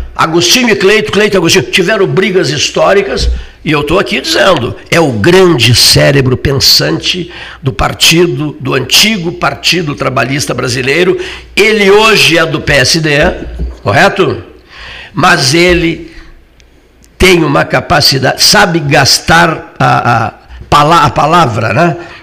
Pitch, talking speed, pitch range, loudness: 165 Hz, 120 wpm, 135-185 Hz, -7 LUFS